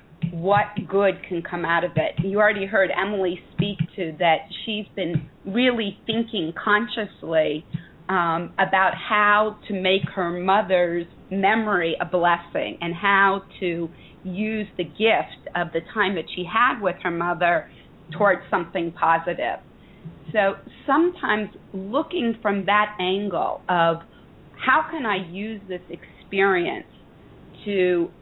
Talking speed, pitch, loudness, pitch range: 130 wpm, 190 Hz, -23 LUFS, 170-205 Hz